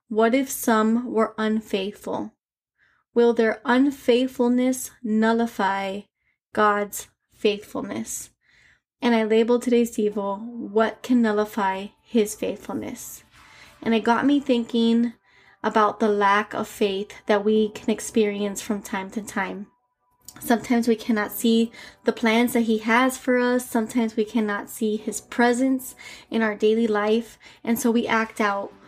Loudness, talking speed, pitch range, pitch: -23 LUFS, 135 wpm, 210-240 Hz, 225 Hz